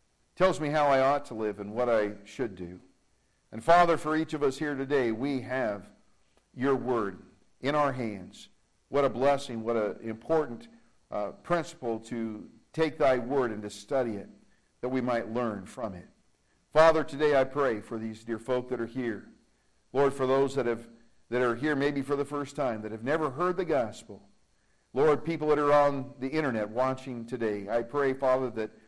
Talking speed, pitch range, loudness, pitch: 190 wpm, 115-145 Hz, -29 LUFS, 130 Hz